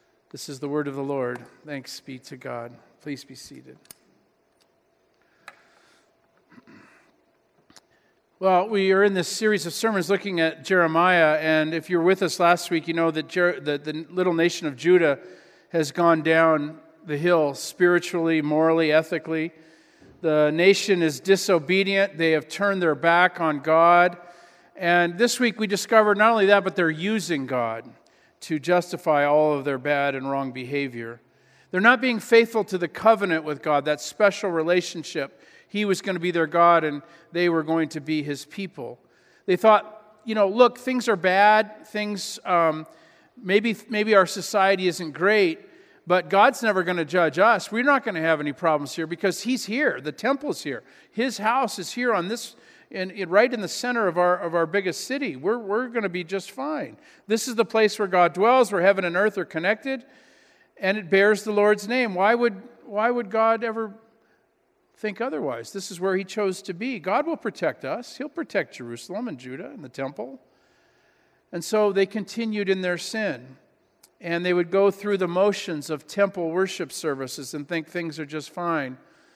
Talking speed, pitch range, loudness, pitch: 180 wpm, 160-215 Hz, -23 LUFS, 180 Hz